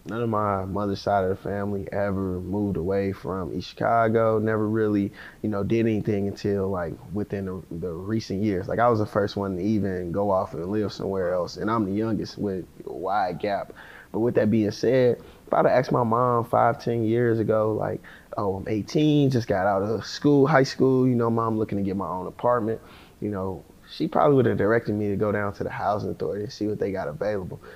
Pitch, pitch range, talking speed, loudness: 105 Hz, 100-115 Hz, 225 wpm, -25 LUFS